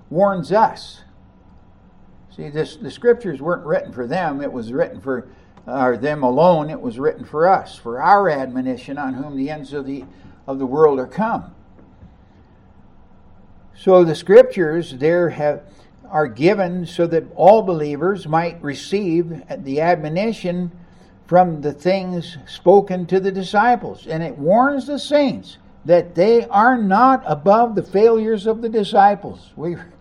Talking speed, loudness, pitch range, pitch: 150 wpm, -18 LUFS, 135-195 Hz, 165 Hz